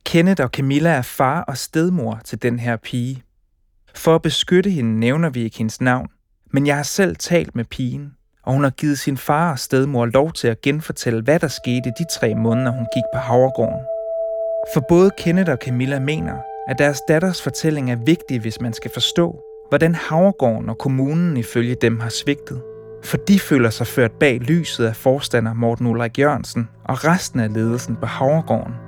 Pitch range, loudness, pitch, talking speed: 115-160 Hz, -19 LUFS, 130 Hz, 190 wpm